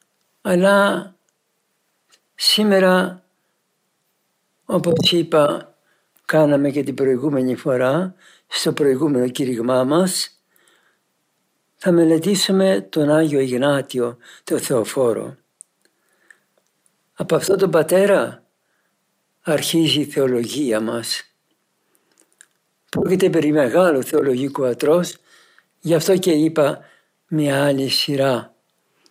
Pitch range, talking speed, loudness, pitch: 135-185 Hz, 80 wpm, -18 LUFS, 155 Hz